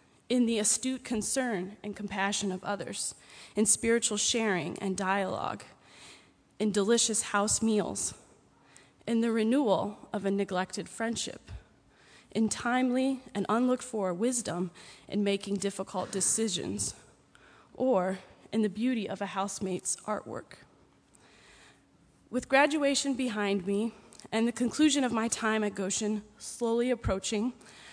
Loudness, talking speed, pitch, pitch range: -30 LUFS, 120 wpm, 215 Hz, 200-235 Hz